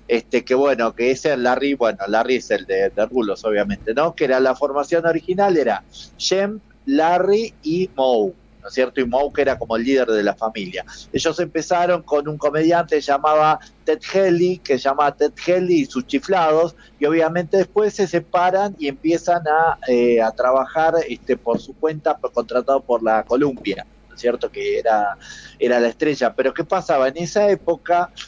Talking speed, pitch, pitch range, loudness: 185 wpm, 155 Hz, 130-175 Hz, -19 LUFS